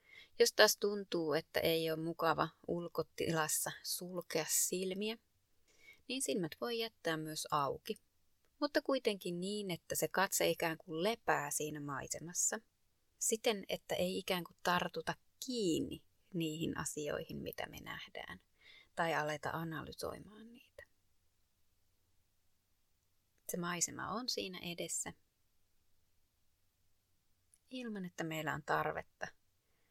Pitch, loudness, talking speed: 165 Hz, -38 LUFS, 105 wpm